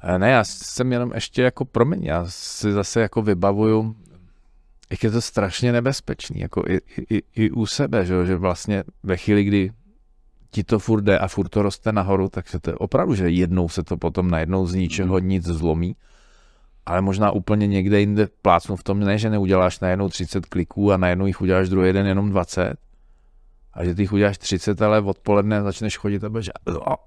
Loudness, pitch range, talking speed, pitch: -21 LUFS, 90-105 Hz, 190 wpm, 100 Hz